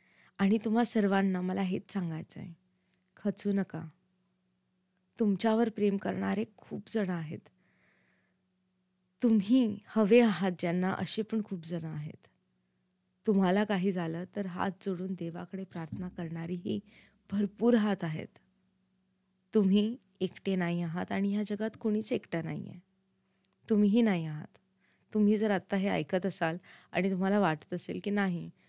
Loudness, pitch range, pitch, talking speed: -31 LUFS, 170-205 Hz, 190 Hz, 130 wpm